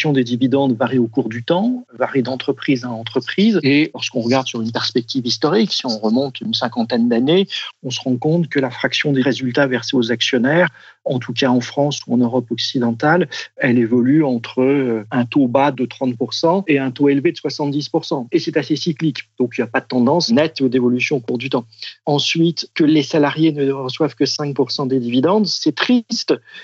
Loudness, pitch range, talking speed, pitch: -17 LUFS, 125-155 Hz, 200 wpm, 135 Hz